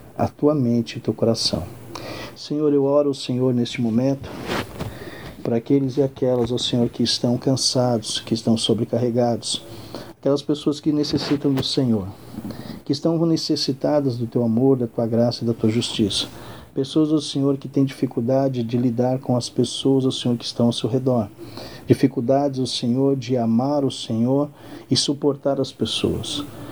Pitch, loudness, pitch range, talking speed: 130 Hz, -21 LUFS, 120-140 Hz, 165 wpm